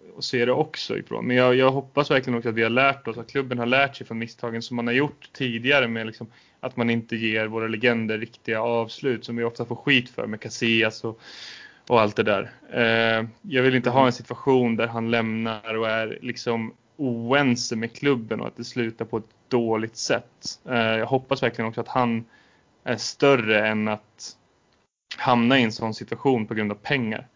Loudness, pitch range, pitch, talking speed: -23 LUFS, 115-125 Hz, 115 Hz, 200 wpm